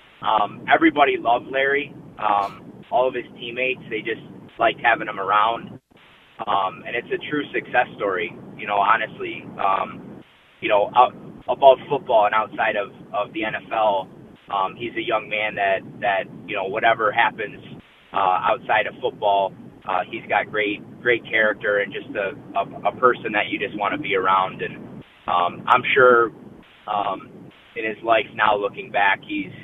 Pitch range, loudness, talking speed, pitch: 100-145 Hz, -21 LUFS, 165 wpm, 110 Hz